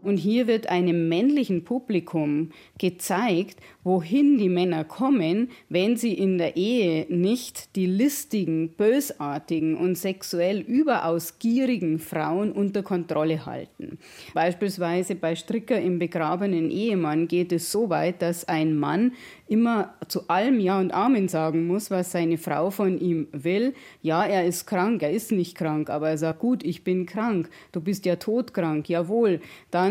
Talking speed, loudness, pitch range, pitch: 155 wpm, -25 LUFS, 165-215 Hz, 180 Hz